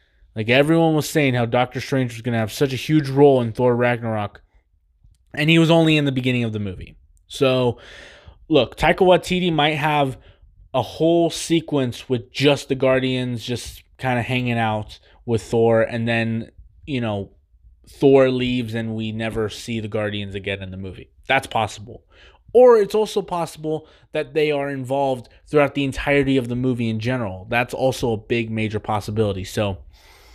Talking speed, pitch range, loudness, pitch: 175 wpm, 110-140 Hz, -20 LUFS, 120 Hz